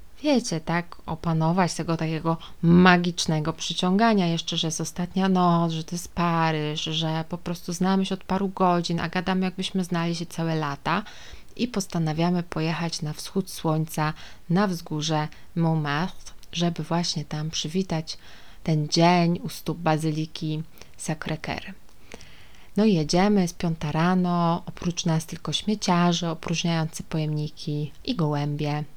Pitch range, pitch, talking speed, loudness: 160-180 Hz, 170 Hz, 135 wpm, -25 LUFS